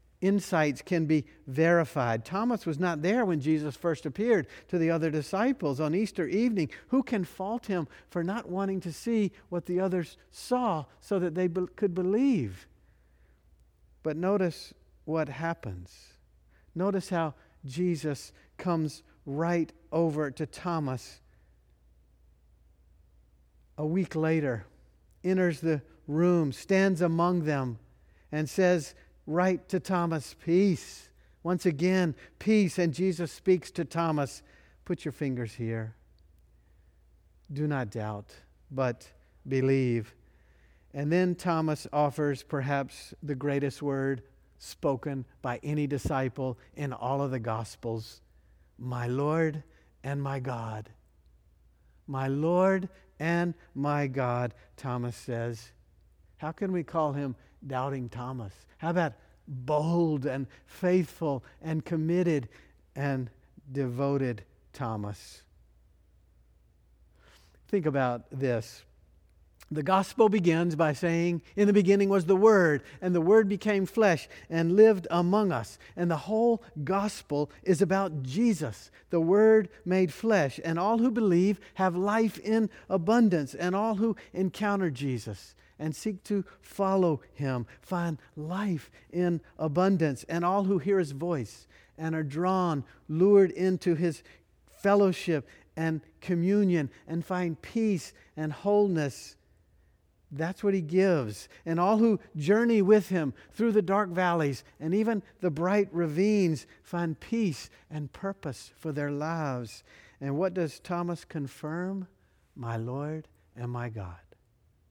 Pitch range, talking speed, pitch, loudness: 120-185 Hz, 125 wpm, 155 Hz, -29 LUFS